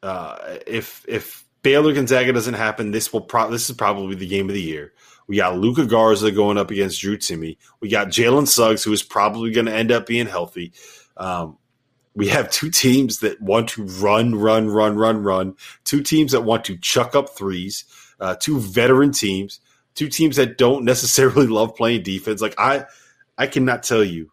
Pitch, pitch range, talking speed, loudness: 110 Hz, 100-125 Hz, 195 wpm, -18 LUFS